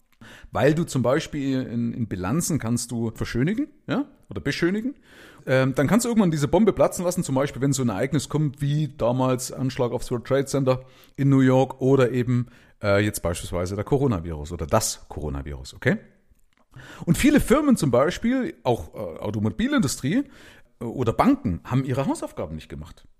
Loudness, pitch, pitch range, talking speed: -24 LUFS, 130 Hz, 115-155 Hz, 170 wpm